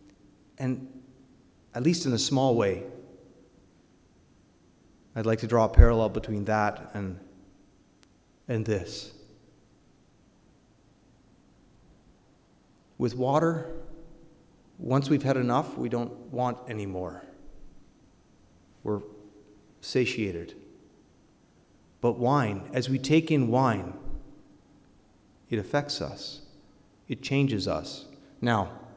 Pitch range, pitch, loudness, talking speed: 100-130 Hz, 115 Hz, -28 LUFS, 95 wpm